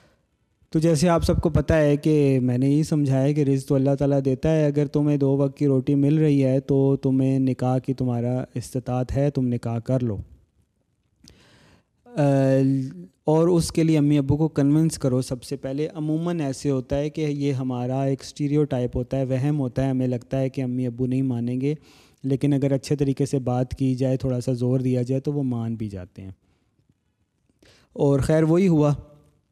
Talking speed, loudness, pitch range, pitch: 200 wpm, -22 LUFS, 130-145 Hz, 135 Hz